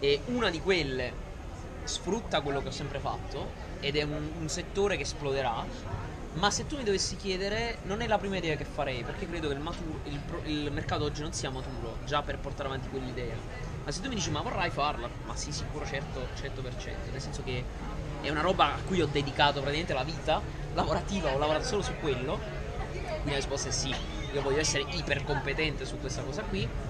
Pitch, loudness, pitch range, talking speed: 140 Hz, -32 LUFS, 125-150 Hz, 210 wpm